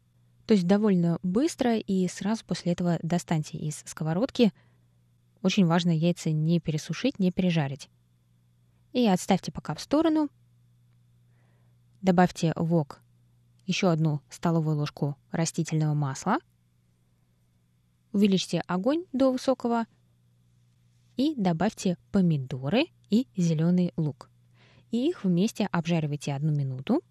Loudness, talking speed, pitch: -27 LUFS, 105 wpm, 165 Hz